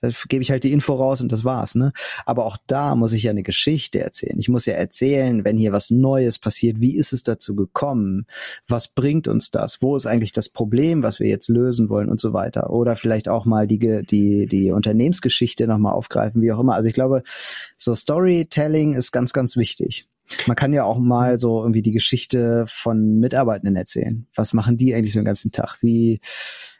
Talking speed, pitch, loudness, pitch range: 215 wpm, 115 Hz, -19 LUFS, 110-130 Hz